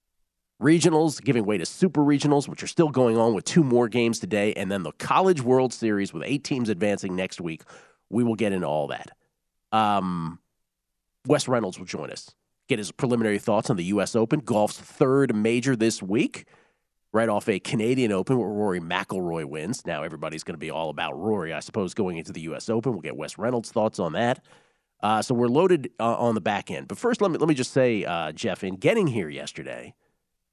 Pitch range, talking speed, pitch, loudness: 100-135 Hz, 210 wpm, 115 Hz, -25 LUFS